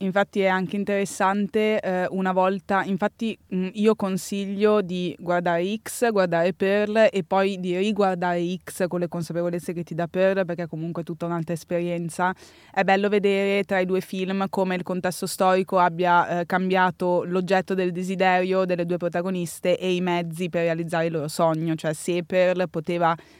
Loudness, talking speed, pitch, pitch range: -24 LUFS, 170 wpm, 185 Hz, 175-195 Hz